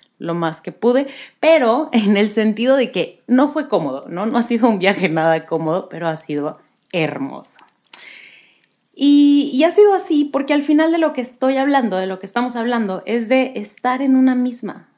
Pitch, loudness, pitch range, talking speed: 240 Hz, -17 LUFS, 190-275 Hz, 195 wpm